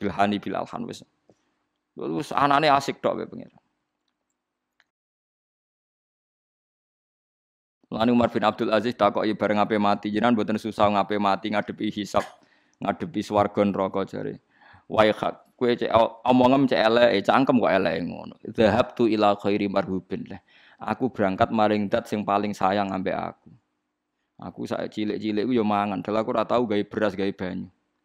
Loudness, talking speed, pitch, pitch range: -24 LUFS, 140 wpm, 105 Hz, 100-110 Hz